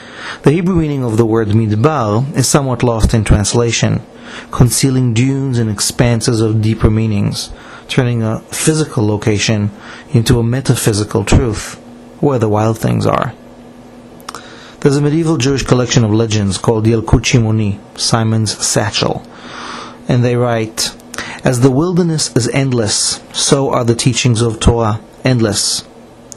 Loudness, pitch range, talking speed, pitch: -13 LUFS, 110-130 Hz, 130 wpm, 115 Hz